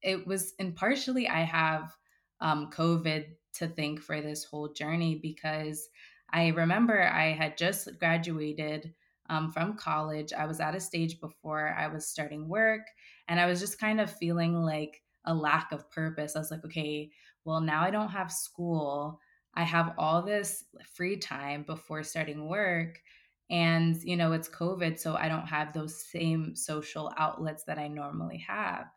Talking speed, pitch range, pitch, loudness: 170 wpm, 155-170 Hz, 160 Hz, -31 LUFS